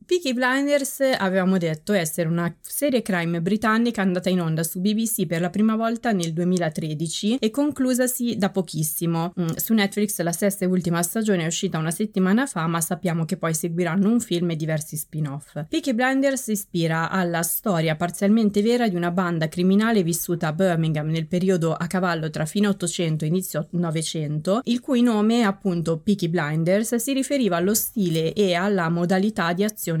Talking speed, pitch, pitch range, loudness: 170 wpm, 185 Hz, 170-215 Hz, -23 LUFS